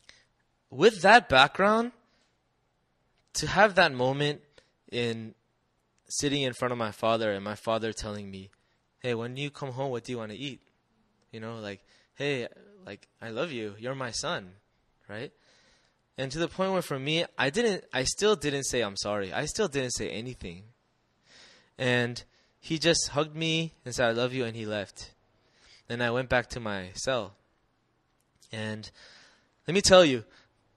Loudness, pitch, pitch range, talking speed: -28 LUFS, 125 Hz, 110-145 Hz, 170 wpm